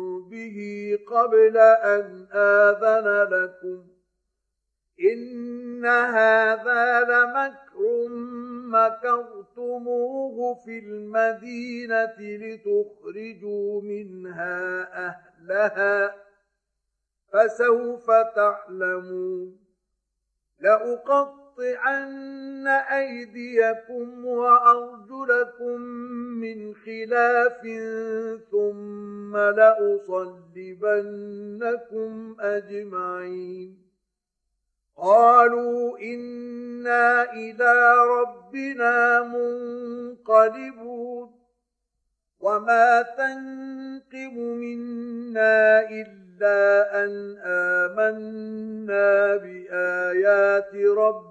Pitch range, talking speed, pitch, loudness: 205-240 Hz, 45 wpm, 225 Hz, -21 LUFS